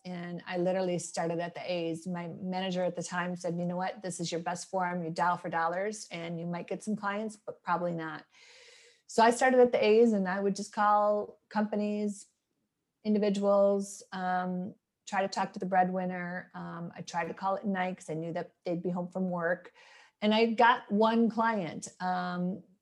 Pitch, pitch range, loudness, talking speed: 185 Hz, 175-210 Hz, -31 LUFS, 200 wpm